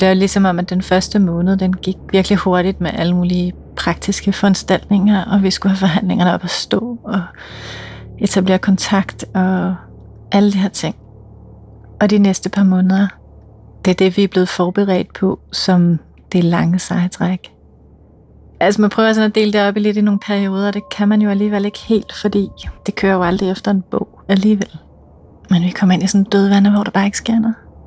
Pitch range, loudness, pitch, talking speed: 180-200 Hz, -15 LUFS, 190 Hz, 200 wpm